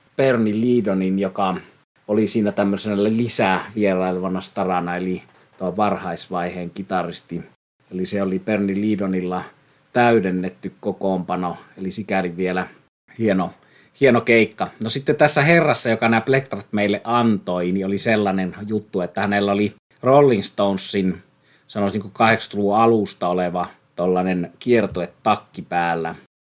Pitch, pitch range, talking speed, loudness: 100 Hz, 90-110 Hz, 120 wpm, -20 LUFS